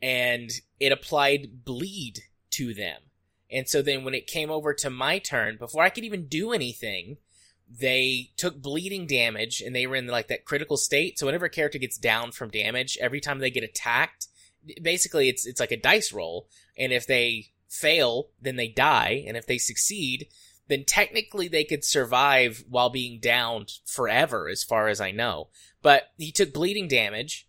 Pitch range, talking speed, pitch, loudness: 120-155 Hz, 185 wpm, 130 Hz, -25 LUFS